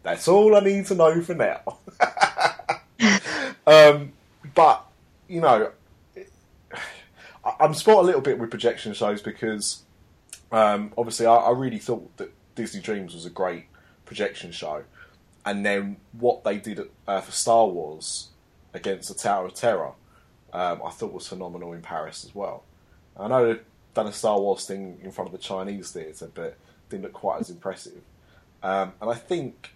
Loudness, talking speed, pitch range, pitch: -22 LUFS, 165 wpm, 95-160 Hz, 115 Hz